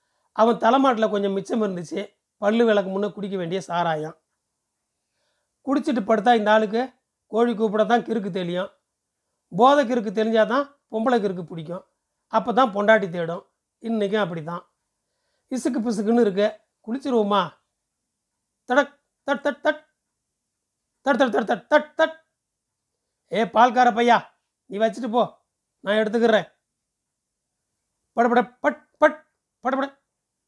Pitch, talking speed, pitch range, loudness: 230 Hz, 115 wpm, 205-265 Hz, -22 LUFS